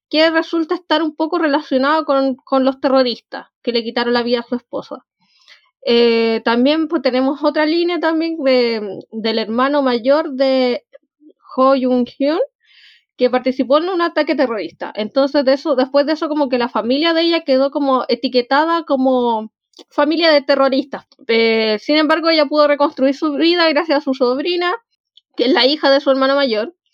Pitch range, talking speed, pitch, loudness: 255-310 Hz, 175 wpm, 275 Hz, -16 LUFS